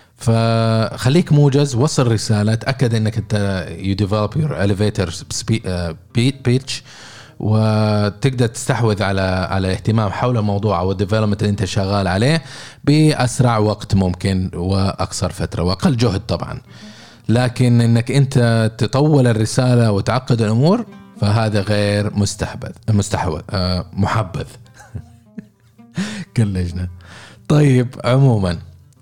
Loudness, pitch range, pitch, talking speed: -17 LUFS, 100-125 Hz, 110 Hz, 90 wpm